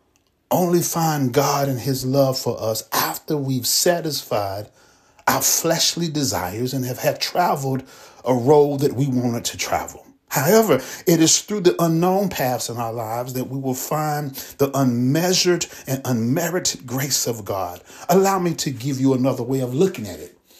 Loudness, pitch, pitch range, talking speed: -20 LUFS, 135 Hz, 125-160 Hz, 165 wpm